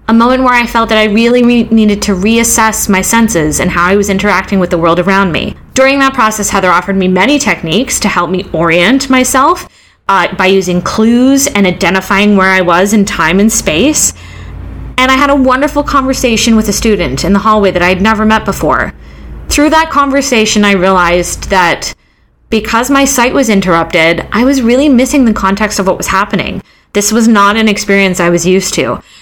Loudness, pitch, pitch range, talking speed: -8 LUFS, 210 Hz, 190-245 Hz, 200 wpm